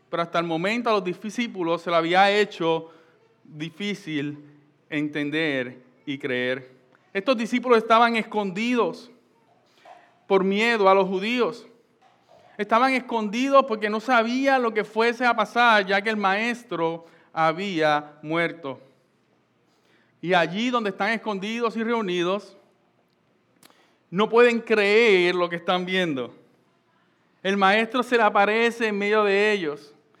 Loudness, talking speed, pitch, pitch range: -22 LUFS, 125 wpm, 195 Hz, 165-225 Hz